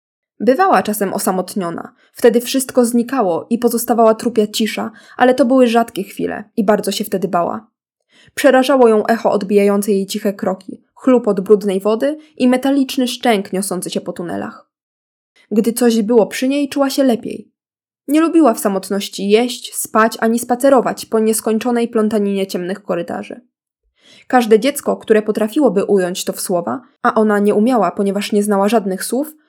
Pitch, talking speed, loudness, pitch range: 225 Hz, 155 wpm, -15 LUFS, 200-250 Hz